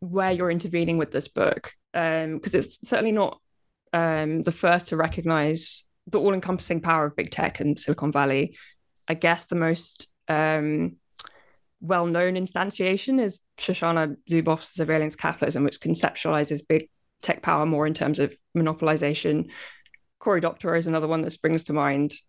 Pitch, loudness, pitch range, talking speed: 160 Hz, -25 LUFS, 155-180 Hz, 155 wpm